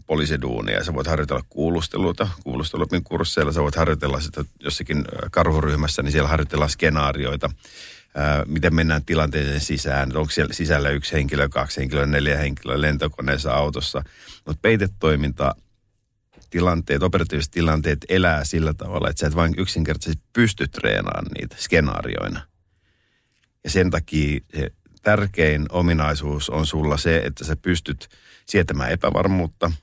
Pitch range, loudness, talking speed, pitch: 75-85 Hz, -22 LUFS, 125 wpm, 75 Hz